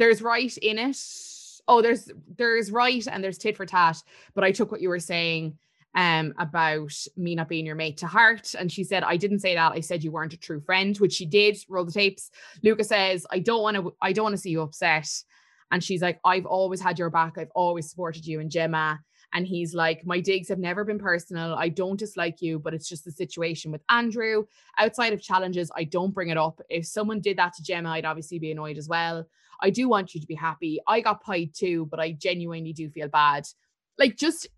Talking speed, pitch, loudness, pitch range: 230 wpm, 180 Hz, -25 LUFS, 165-205 Hz